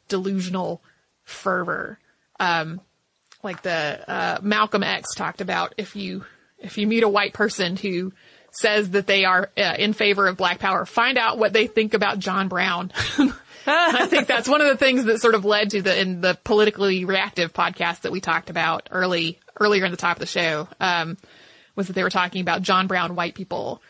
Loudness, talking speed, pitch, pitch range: -21 LUFS, 195 wpm, 195 Hz, 180-210 Hz